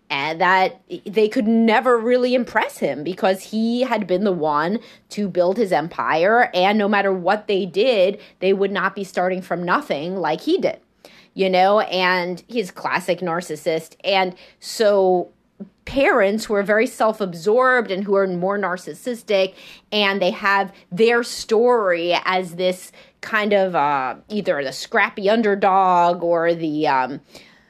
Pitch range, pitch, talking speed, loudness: 180-220 Hz, 195 Hz, 150 wpm, -19 LUFS